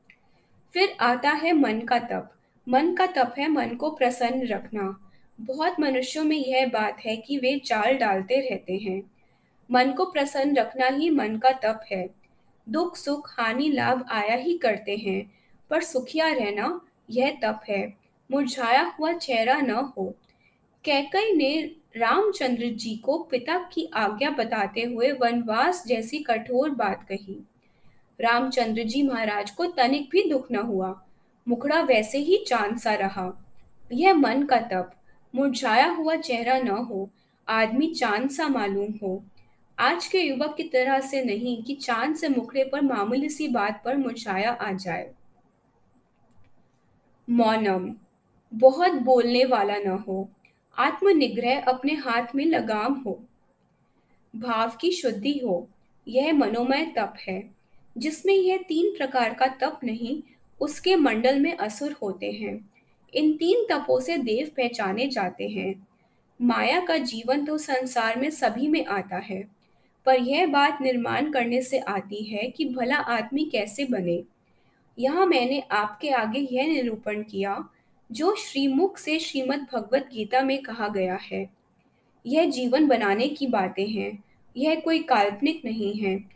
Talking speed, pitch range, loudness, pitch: 145 wpm, 220-290 Hz, -24 LUFS, 255 Hz